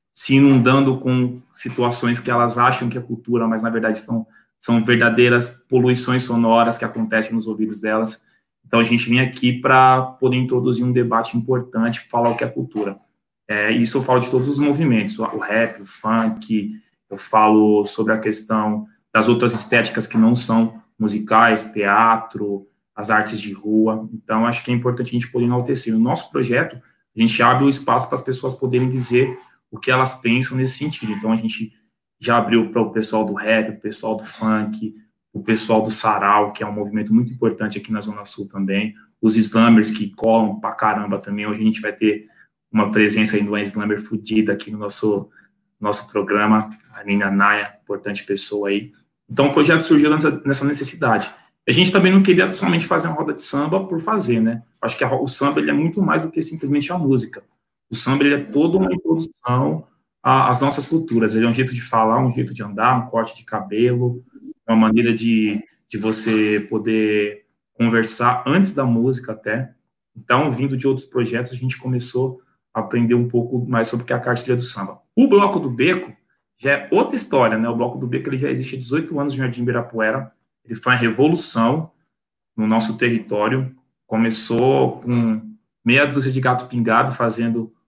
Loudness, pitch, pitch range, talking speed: -18 LUFS, 115 Hz, 110-125 Hz, 195 wpm